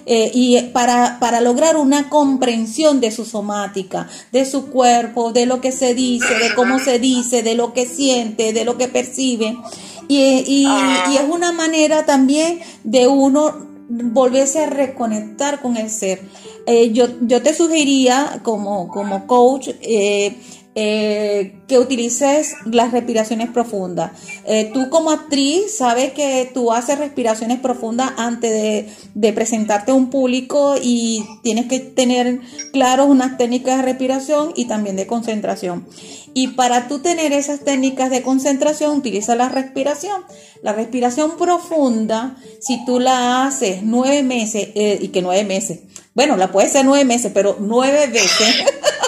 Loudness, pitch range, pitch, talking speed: -16 LUFS, 225-275 Hz, 250 Hz, 150 wpm